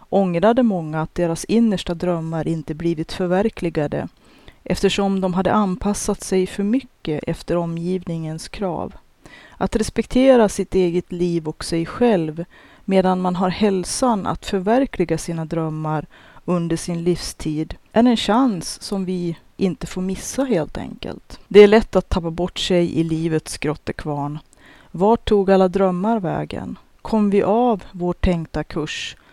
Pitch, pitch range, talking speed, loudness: 185 Hz, 165-205 Hz, 140 wpm, -20 LUFS